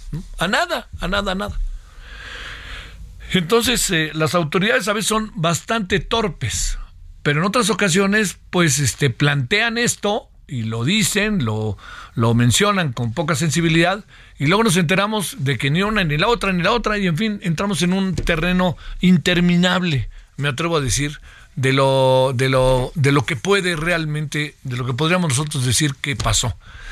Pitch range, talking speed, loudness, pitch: 130-195 Hz, 165 wpm, -18 LUFS, 165 Hz